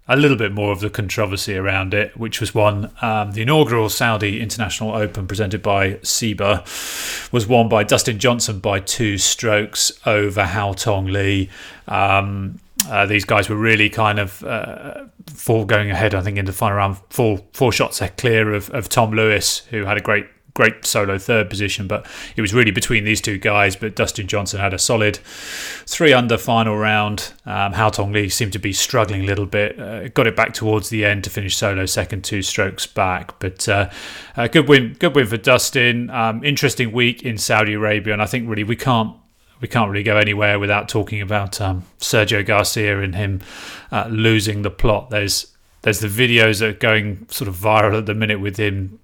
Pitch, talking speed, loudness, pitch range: 105 Hz, 200 wpm, -18 LUFS, 100-115 Hz